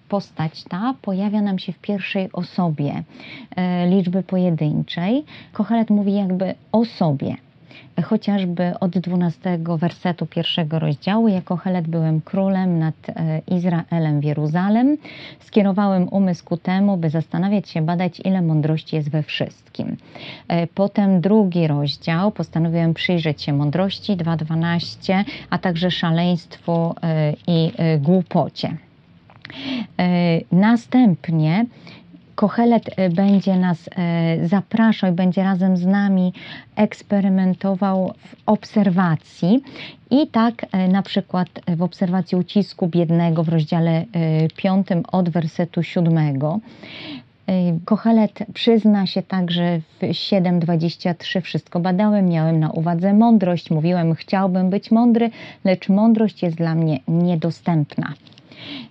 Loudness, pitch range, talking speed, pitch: -19 LUFS, 165-200 Hz, 110 wpm, 180 Hz